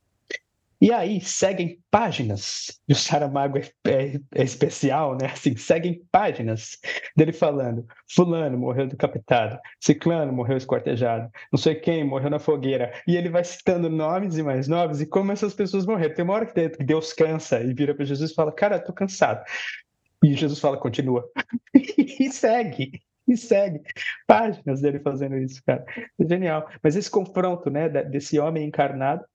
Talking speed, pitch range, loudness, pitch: 165 wpm, 140-185 Hz, -23 LUFS, 155 Hz